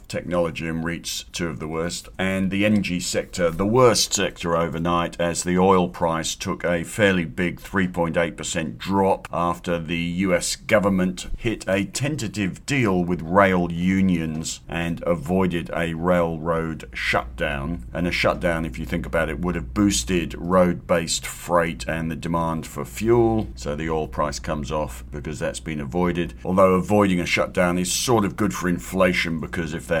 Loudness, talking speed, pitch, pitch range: -23 LUFS, 165 wpm, 85 Hz, 80-95 Hz